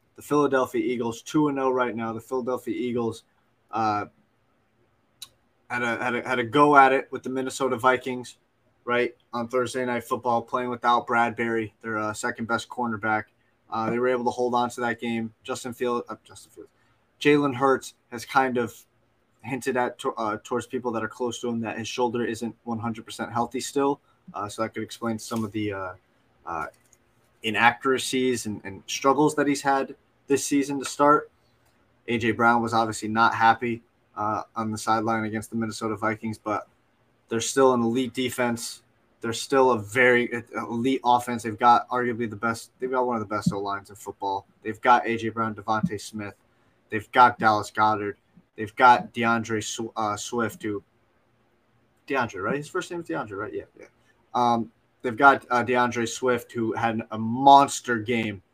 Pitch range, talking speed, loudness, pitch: 115-125 Hz, 180 wpm, -25 LUFS, 120 Hz